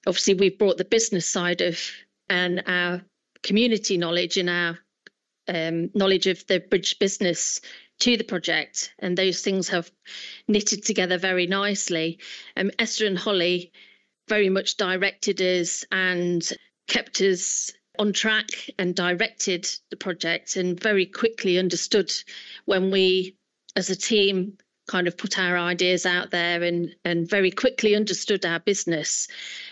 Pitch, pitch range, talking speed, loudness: 185 Hz, 180-205 Hz, 145 wpm, -23 LUFS